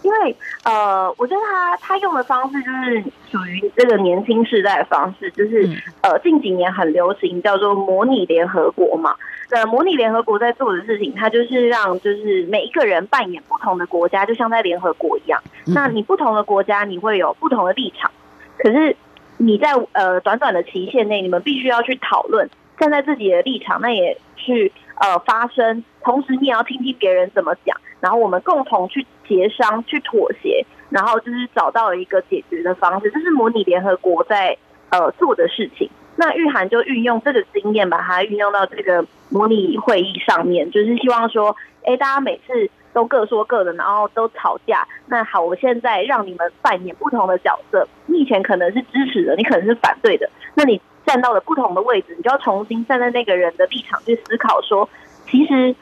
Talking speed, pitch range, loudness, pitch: 300 characters per minute, 200-280 Hz, -17 LUFS, 235 Hz